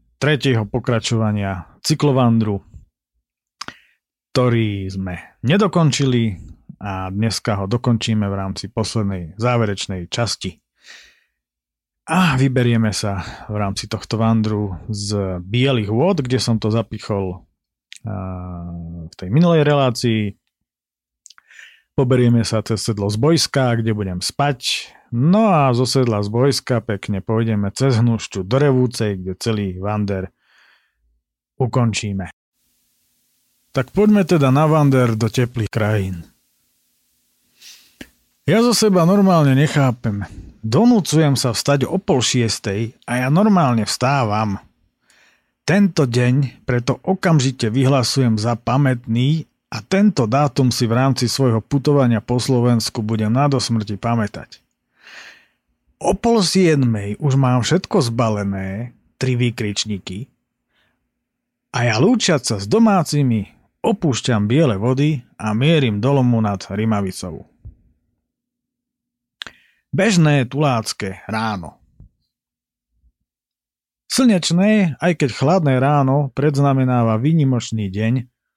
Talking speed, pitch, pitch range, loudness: 105 wpm, 120 Hz, 105-140 Hz, -18 LUFS